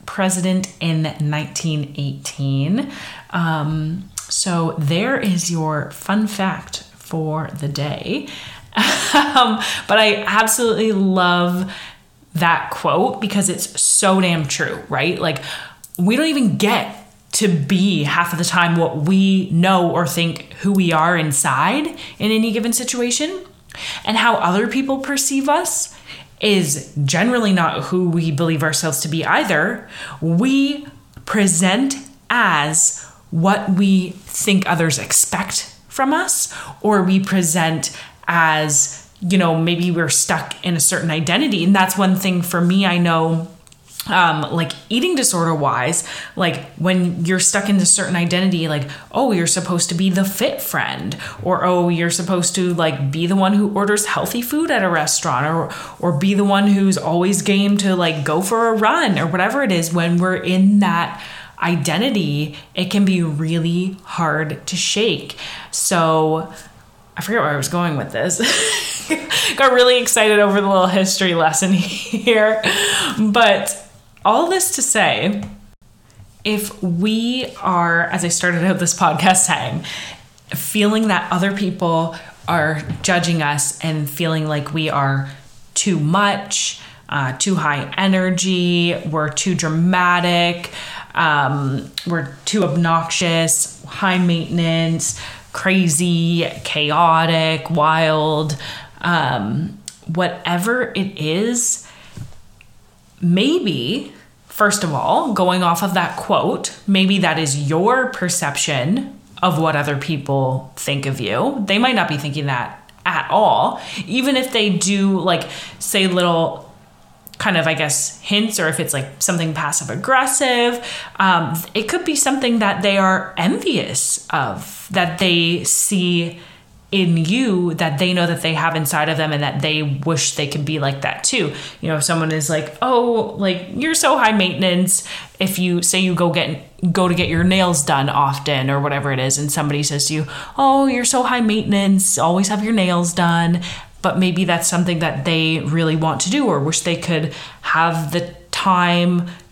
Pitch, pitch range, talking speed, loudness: 175 Hz, 160-195 Hz, 150 wpm, -17 LUFS